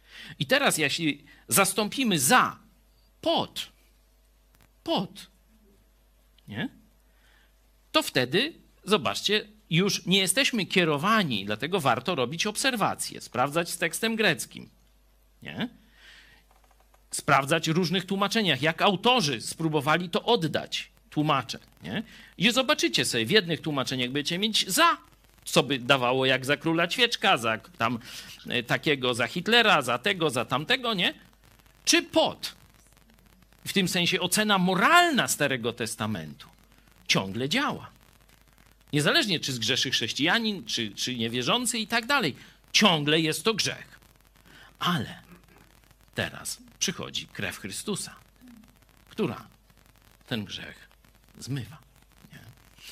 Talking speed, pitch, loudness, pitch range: 105 wpm, 175 Hz, -25 LUFS, 140-215 Hz